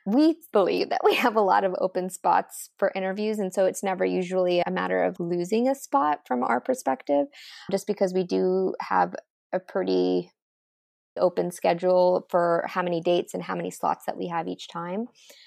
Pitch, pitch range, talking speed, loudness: 180 Hz, 130-195 Hz, 185 wpm, -25 LUFS